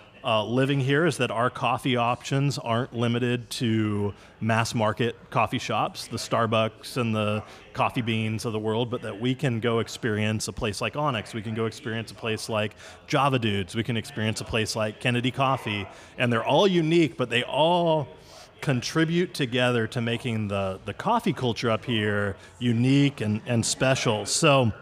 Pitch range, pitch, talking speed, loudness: 110-130 Hz, 115 Hz, 175 wpm, -26 LUFS